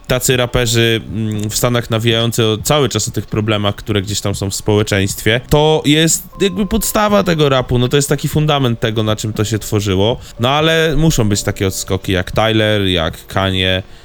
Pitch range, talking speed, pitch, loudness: 105-145 Hz, 190 wpm, 115 Hz, -14 LUFS